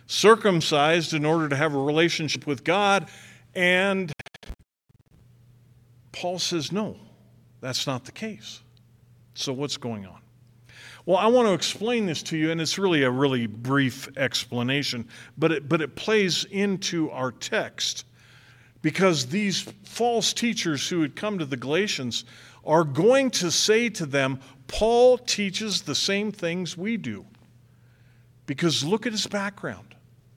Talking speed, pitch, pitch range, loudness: 140 wpm, 150 Hz, 125-190 Hz, -24 LUFS